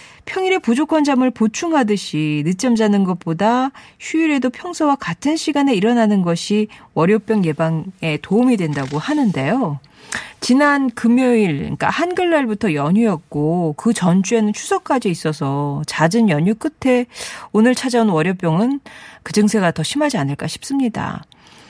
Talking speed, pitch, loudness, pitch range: 315 characters per minute, 220 Hz, -17 LUFS, 170-265 Hz